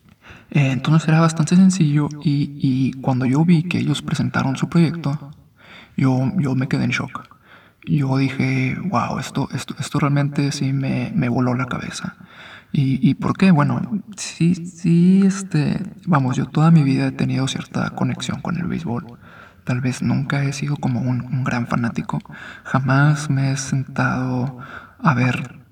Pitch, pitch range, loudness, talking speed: 145 Hz, 130-165 Hz, -19 LUFS, 160 wpm